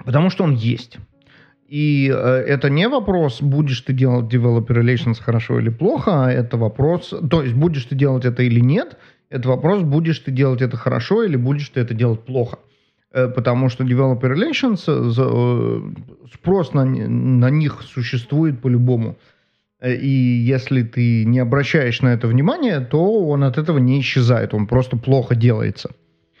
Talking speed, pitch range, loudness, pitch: 165 wpm, 125-145 Hz, -18 LUFS, 130 Hz